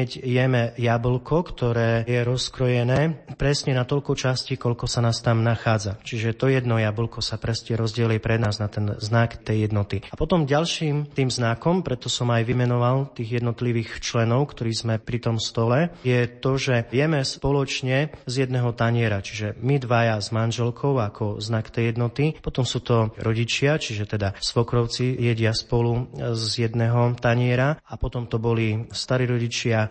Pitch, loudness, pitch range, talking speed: 120 Hz, -23 LUFS, 115-130 Hz, 160 wpm